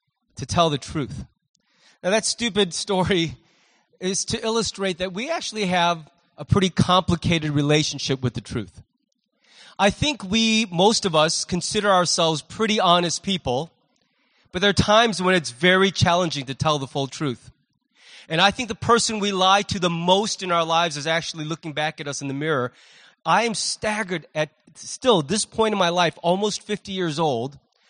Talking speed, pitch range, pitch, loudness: 175 wpm, 155-210 Hz, 180 Hz, -21 LUFS